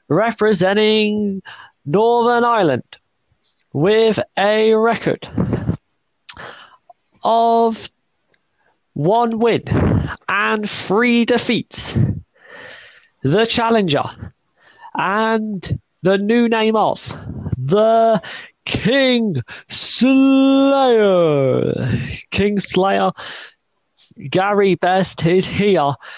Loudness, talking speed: -16 LUFS, 65 wpm